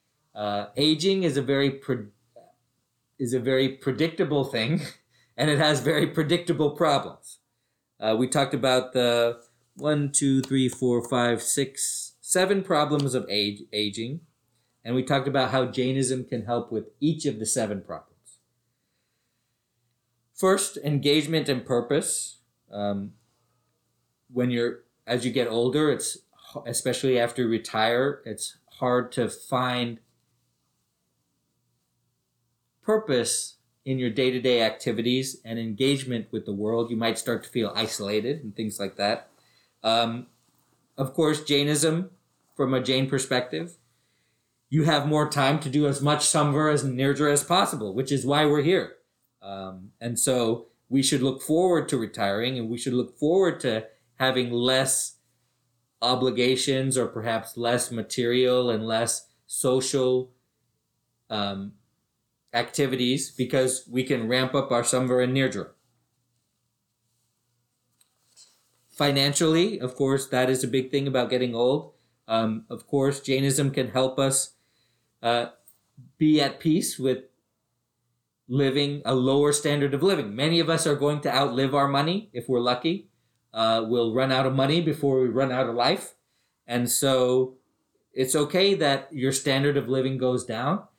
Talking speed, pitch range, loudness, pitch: 140 wpm, 120-140 Hz, -25 LUFS, 130 Hz